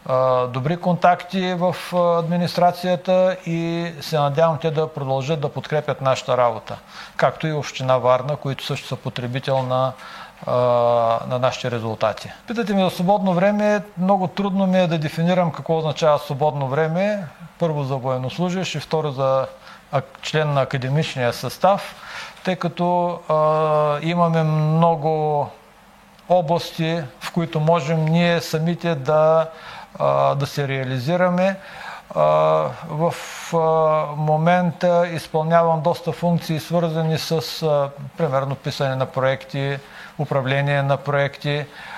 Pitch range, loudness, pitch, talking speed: 135-175 Hz, -20 LUFS, 155 Hz, 115 wpm